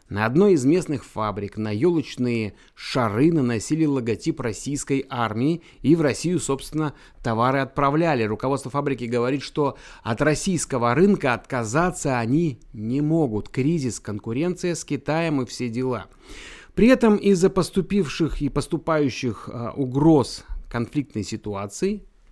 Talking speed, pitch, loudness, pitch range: 120 wpm, 135 Hz, -23 LUFS, 120-160 Hz